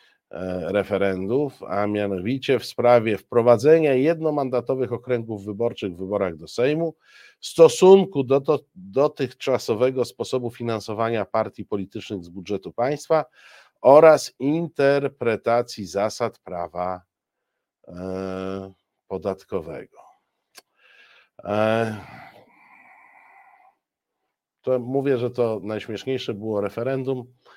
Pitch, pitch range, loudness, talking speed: 120 Hz, 100-135 Hz, -22 LUFS, 85 wpm